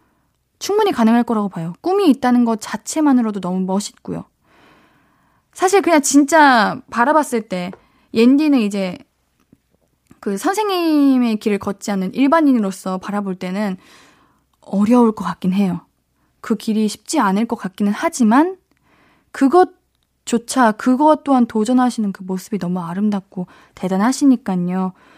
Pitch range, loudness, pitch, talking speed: 200-280 Hz, -17 LUFS, 225 Hz, 285 characters per minute